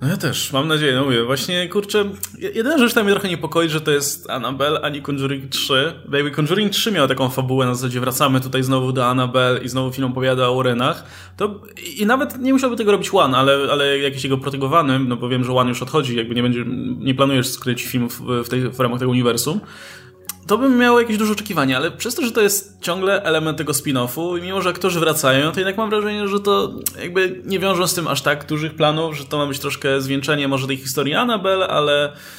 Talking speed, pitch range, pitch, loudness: 225 wpm, 130-190 Hz, 145 Hz, -18 LUFS